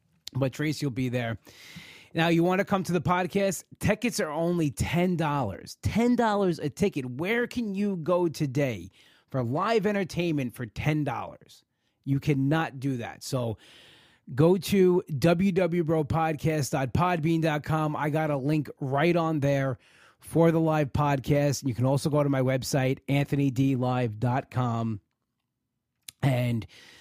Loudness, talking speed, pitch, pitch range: -27 LUFS, 130 wpm, 145 Hz, 130-170 Hz